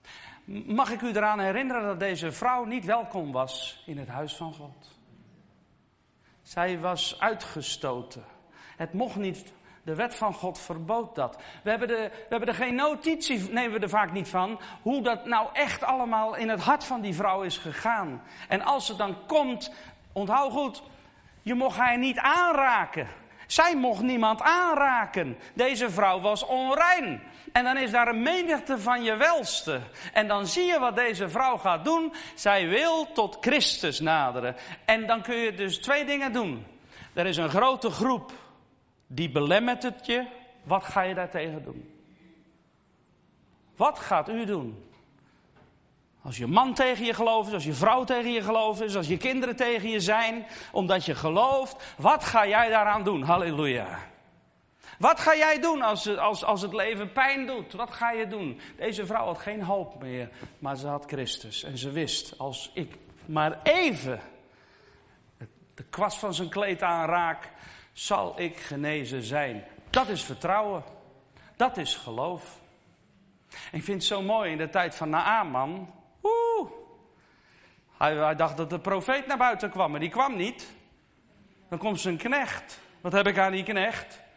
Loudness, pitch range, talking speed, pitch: -27 LUFS, 170-250 Hz, 165 wpm, 210 Hz